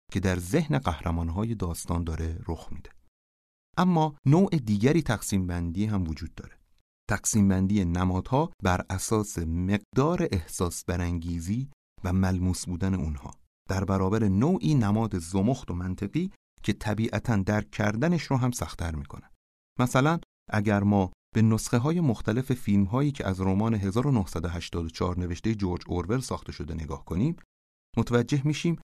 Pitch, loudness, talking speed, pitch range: 95 Hz, -27 LUFS, 135 wpm, 85-120 Hz